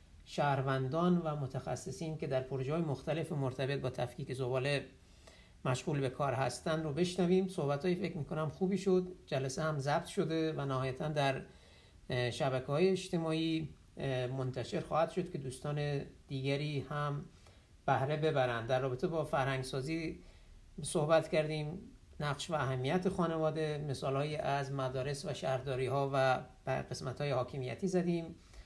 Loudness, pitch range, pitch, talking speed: -36 LUFS, 130-160 Hz, 145 Hz, 140 wpm